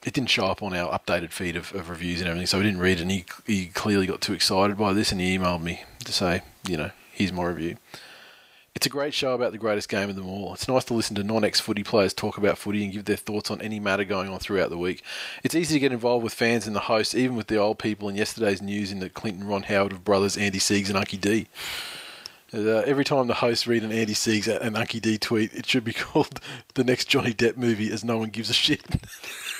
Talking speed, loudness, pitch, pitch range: 265 wpm, -25 LUFS, 105 Hz, 95-115 Hz